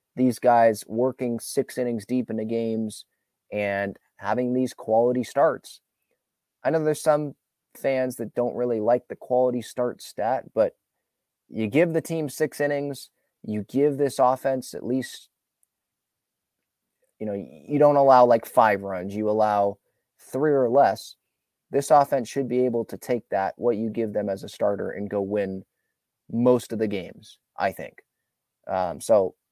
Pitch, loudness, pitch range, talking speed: 125 Hz, -24 LUFS, 110-135 Hz, 160 wpm